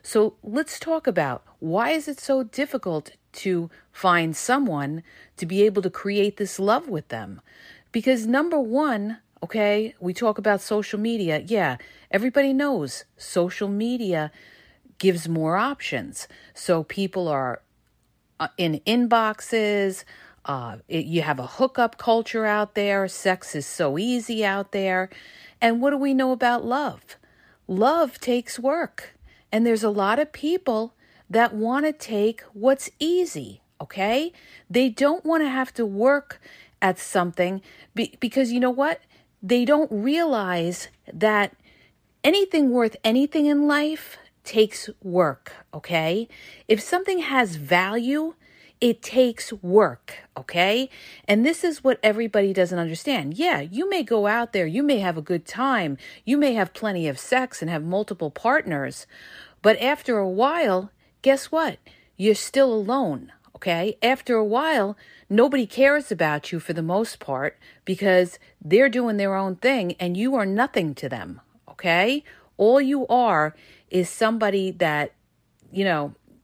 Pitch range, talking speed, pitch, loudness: 185-260 Hz, 145 wpm, 220 Hz, -23 LUFS